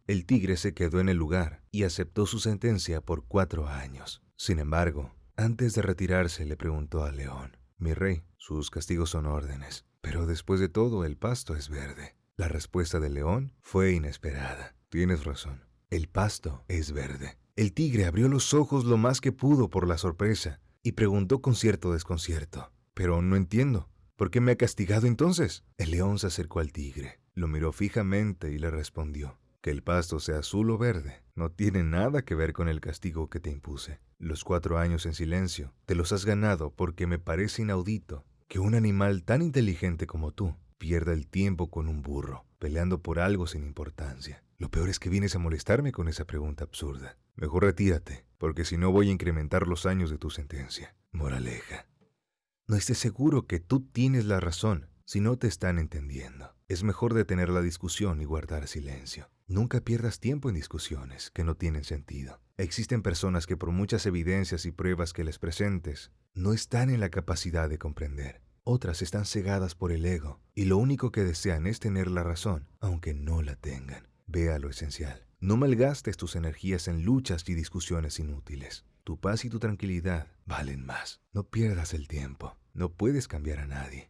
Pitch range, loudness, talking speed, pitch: 75-100 Hz, -30 LUFS, 185 wpm, 85 Hz